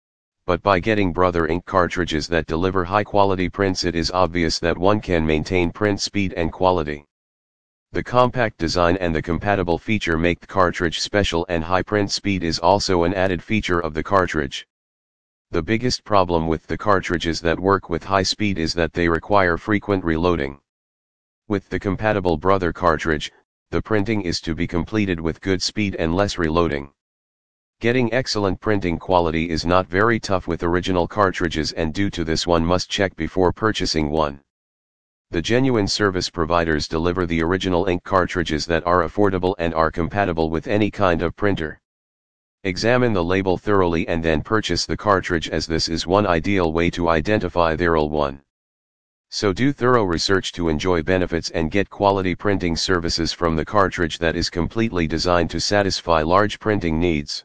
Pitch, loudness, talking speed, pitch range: 90 Hz, -20 LUFS, 170 wpm, 80-100 Hz